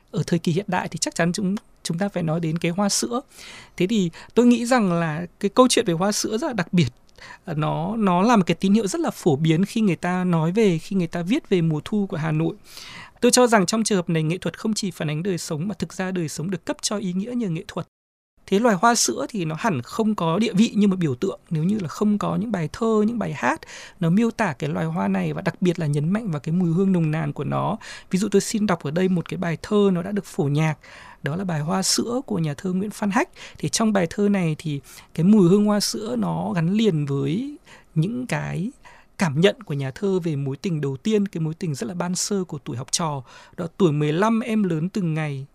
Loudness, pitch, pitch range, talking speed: -22 LUFS, 180 Hz, 160-210 Hz, 270 wpm